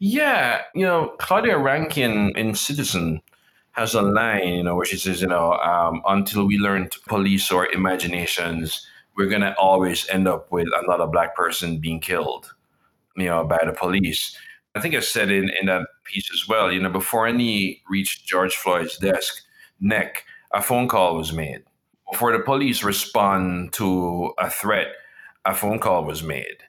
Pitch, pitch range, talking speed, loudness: 95 Hz, 90-100 Hz, 175 wpm, -21 LUFS